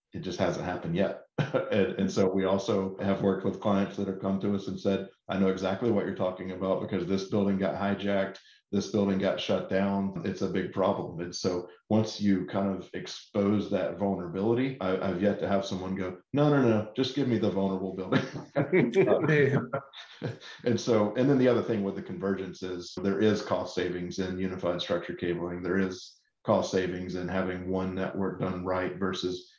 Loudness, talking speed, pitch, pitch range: -29 LUFS, 200 wpm, 95 Hz, 95-100 Hz